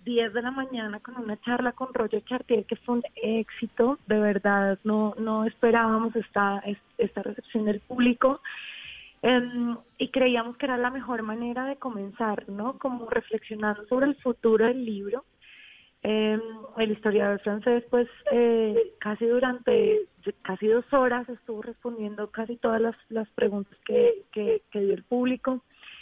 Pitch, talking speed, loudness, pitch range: 230 Hz, 150 wpm, -27 LUFS, 215-250 Hz